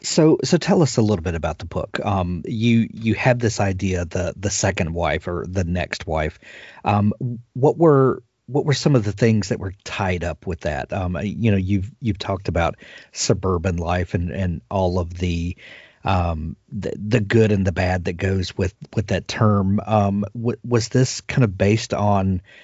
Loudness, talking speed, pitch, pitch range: -21 LUFS, 195 wpm, 100 Hz, 90-115 Hz